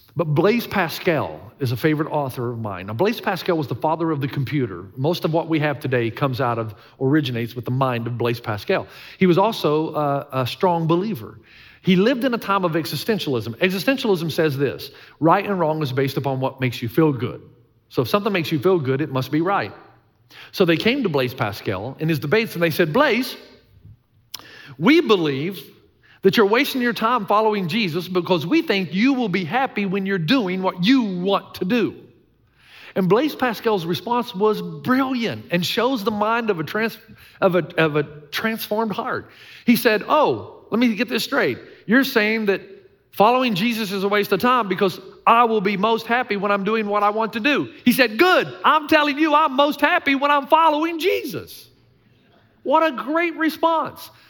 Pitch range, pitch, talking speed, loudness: 150-230 Hz, 190 Hz, 195 wpm, -20 LUFS